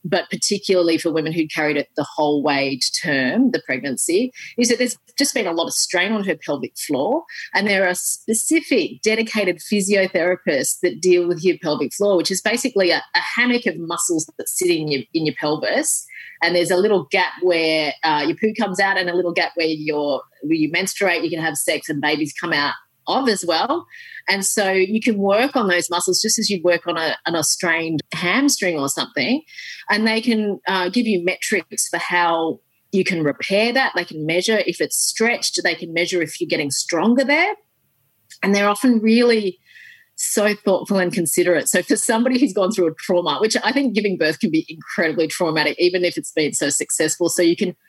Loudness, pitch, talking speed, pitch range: -19 LUFS, 185 Hz, 205 wpm, 165-225 Hz